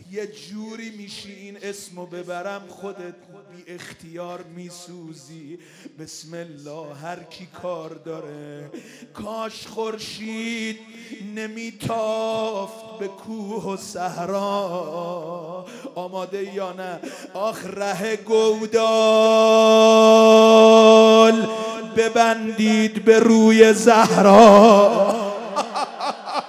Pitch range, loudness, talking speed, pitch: 180-220 Hz, -15 LUFS, 75 wpm, 205 Hz